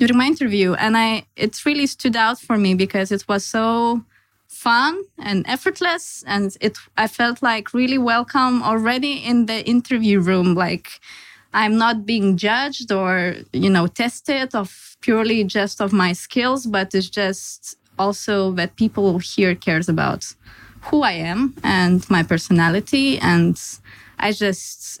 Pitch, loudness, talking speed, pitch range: 215 Hz, -19 LUFS, 150 wpm, 190-245 Hz